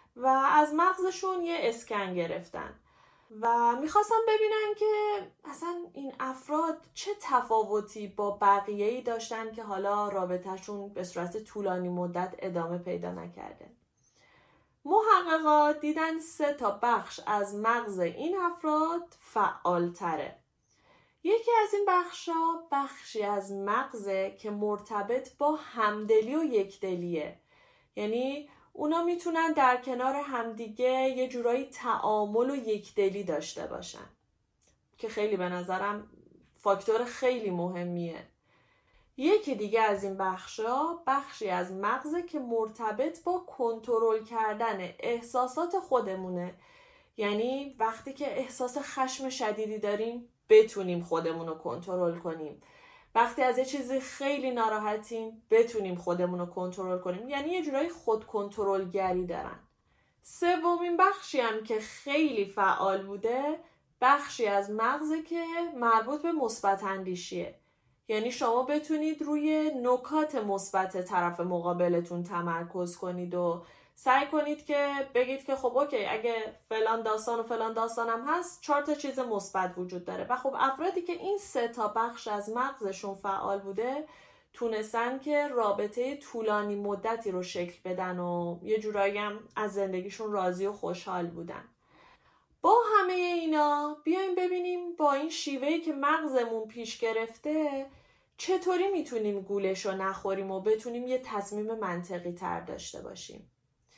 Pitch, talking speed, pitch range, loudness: 230 Hz, 125 wpm, 200-295 Hz, -30 LUFS